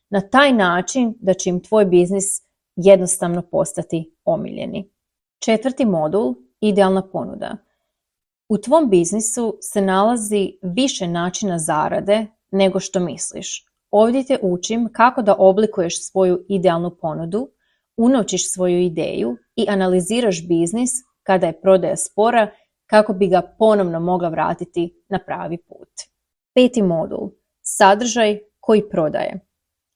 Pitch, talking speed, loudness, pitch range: 195 Hz, 120 wpm, -18 LUFS, 180-220 Hz